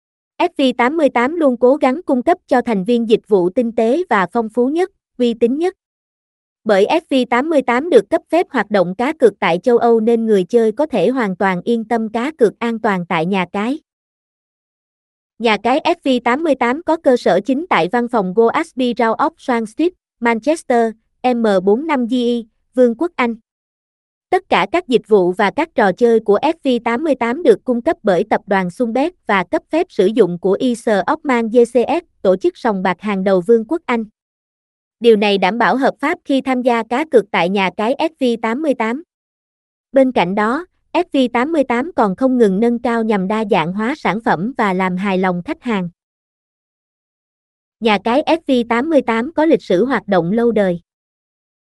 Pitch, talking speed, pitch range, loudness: 240 Hz, 175 wpm, 215-275 Hz, -16 LUFS